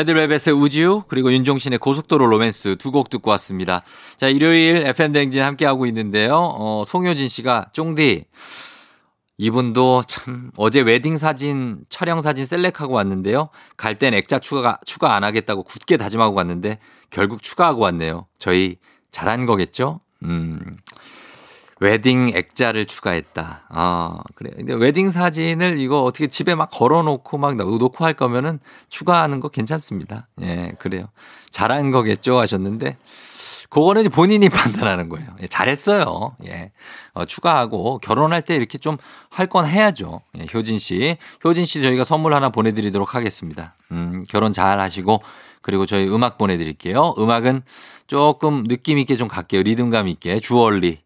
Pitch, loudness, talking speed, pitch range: 125 Hz, -18 LUFS, 325 characters per minute, 105-150 Hz